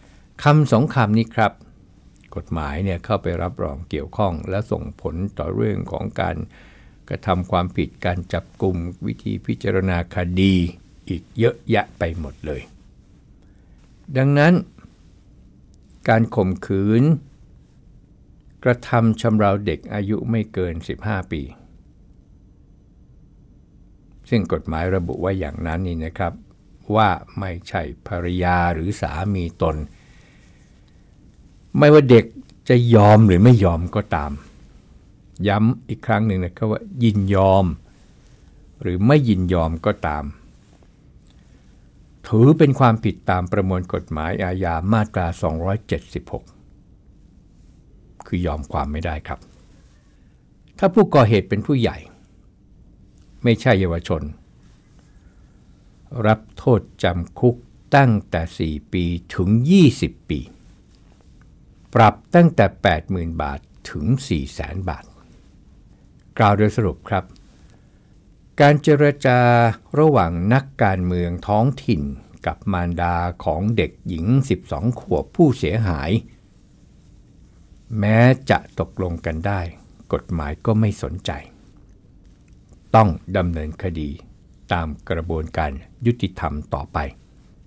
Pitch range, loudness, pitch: 85-110 Hz, -20 LUFS, 95 Hz